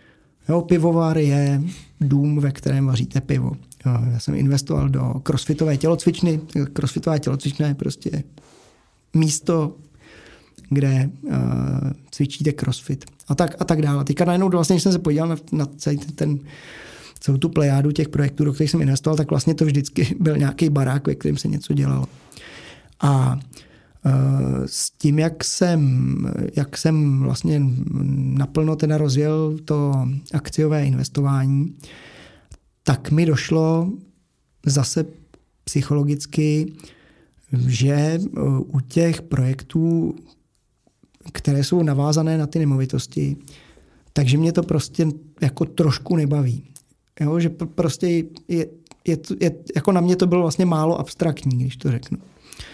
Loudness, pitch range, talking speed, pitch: -21 LUFS, 135-160 Hz, 130 wpm, 145 Hz